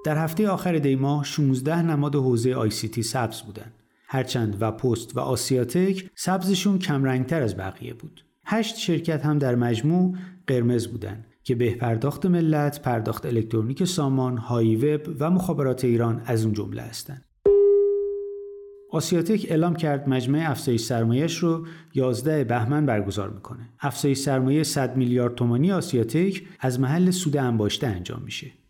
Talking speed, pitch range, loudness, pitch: 145 wpm, 120-165 Hz, -24 LUFS, 135 Hz